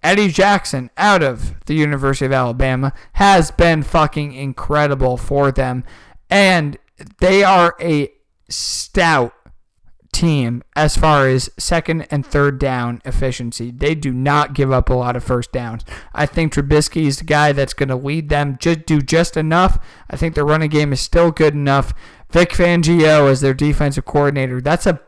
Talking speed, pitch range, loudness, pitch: 165 wpm, 135-160 Hz, -16 LUFS, 145 Hz